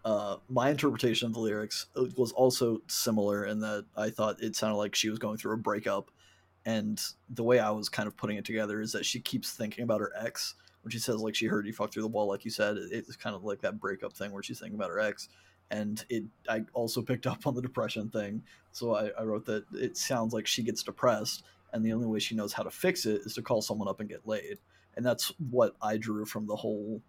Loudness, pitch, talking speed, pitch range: -32 LUFS, 110 Hz, 255 wpm, 105-115 Hz